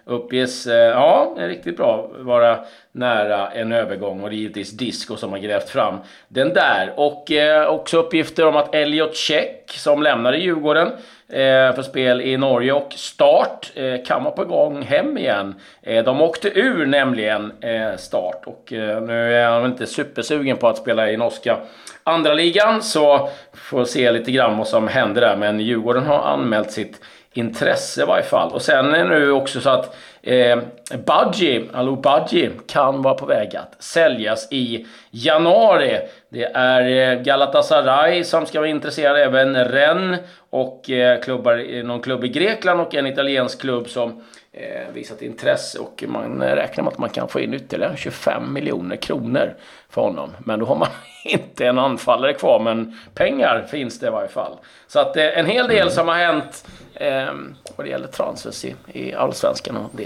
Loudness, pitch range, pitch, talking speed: -18 LUFS, 120-150 Hz, 130 Hz, 175 wpm